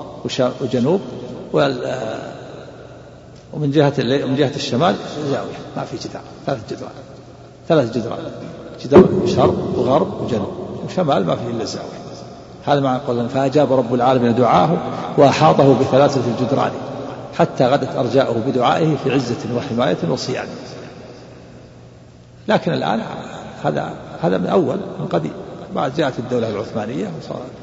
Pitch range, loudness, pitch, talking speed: 120-140 Hz, -18 LUFS, 135 Hz, 120 wpm